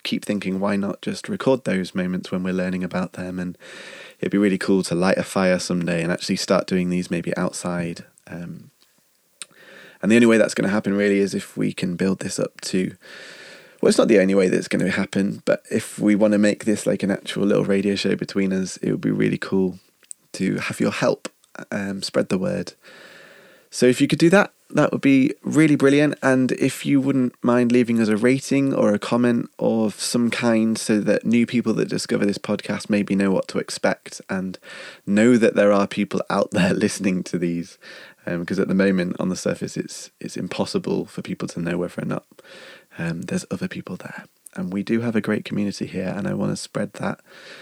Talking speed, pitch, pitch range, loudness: 220 wpm, 100 Hz, 95-120 Hz, -21 LUFS